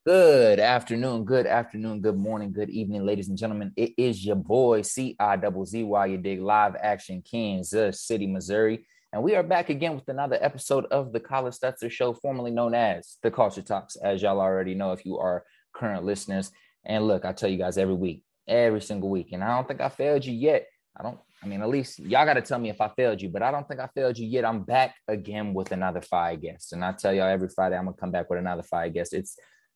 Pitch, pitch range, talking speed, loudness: 105 Hz, 95-130 Hz, 235 wpm, -26 LUFS